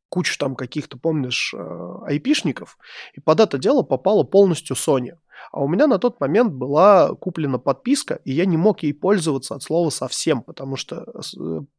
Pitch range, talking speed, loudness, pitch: 135-195 Hz, 165 wpm, -20 LUFS, 155 Hz